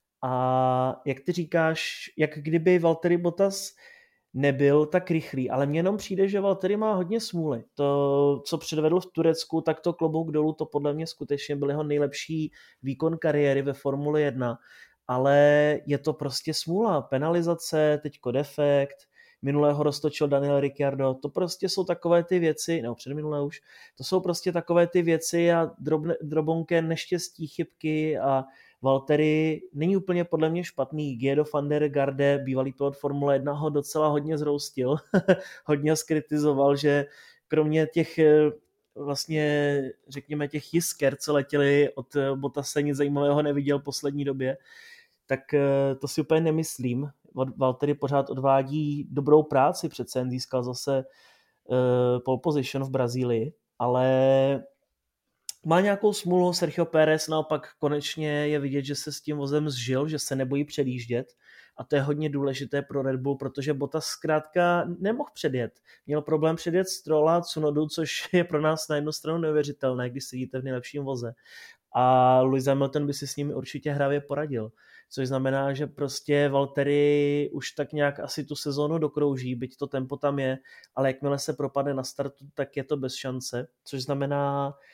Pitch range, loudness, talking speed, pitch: 140-160 Hz, -26 LUFS, 160 wpm, 145 Hz